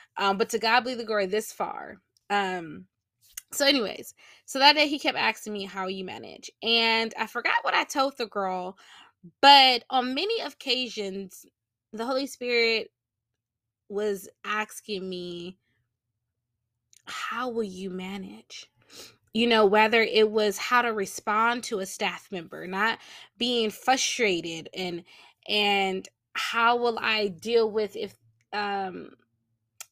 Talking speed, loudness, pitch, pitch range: 140 wpm, -25 LUFS, 210 Hz, 180-235 Hz